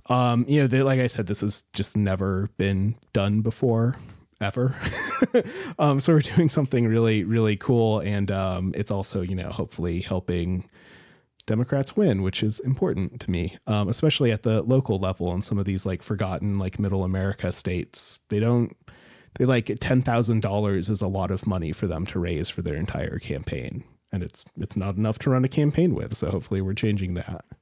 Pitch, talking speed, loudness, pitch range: 105 Hz, 195 wpm, -25 LUFS, 95-125 Hz